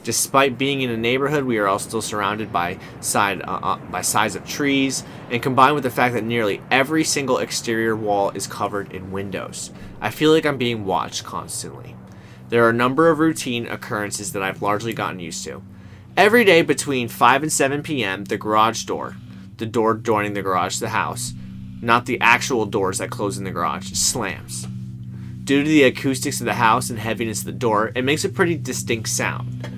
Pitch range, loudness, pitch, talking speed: 95-135 Hz, -20 LUFS, 115 Hz, 200 wpm